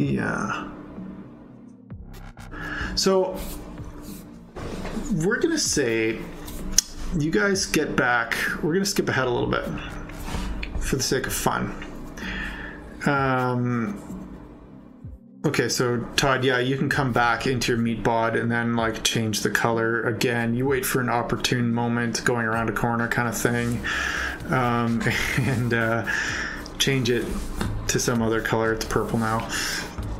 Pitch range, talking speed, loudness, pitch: 115-130 Hz, 130 wpm, -24 LUFS, 120 Hz